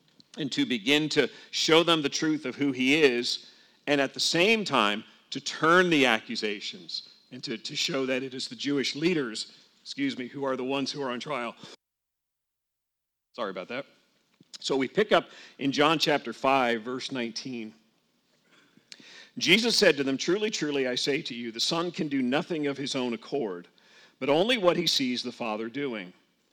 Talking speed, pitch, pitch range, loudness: 185 wpm, 135 Hz, 120-150 Hz, -27 LUFS